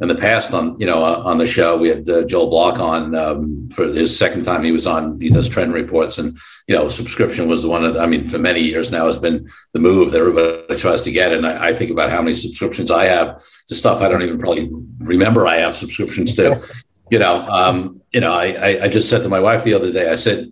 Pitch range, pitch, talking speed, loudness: 80-85 Hz, 80 Hz, 255 wpm, -16 LUFS